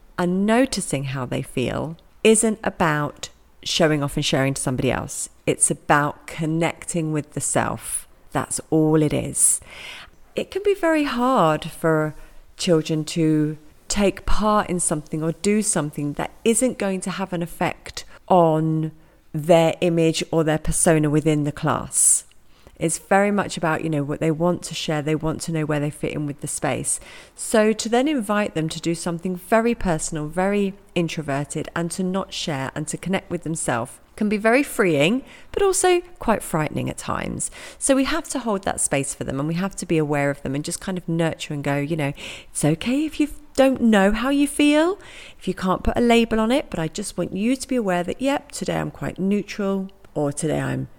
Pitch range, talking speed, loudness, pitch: 155-210 Hz, 200 wpm, -22 LUFS, 170 Hz